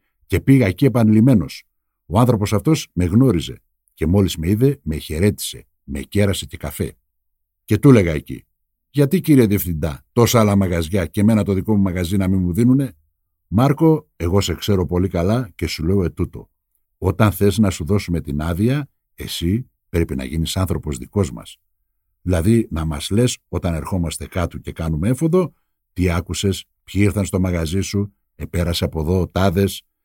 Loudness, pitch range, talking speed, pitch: -19 LUFS, 85-105 Hz, 170 wpm, 95 Hz